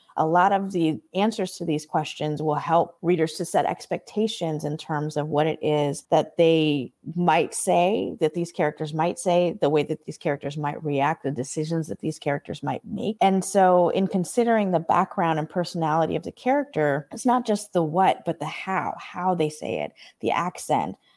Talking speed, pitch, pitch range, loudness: 195 wpm, 160 Hz, 150-180 Hz, -24 LUFS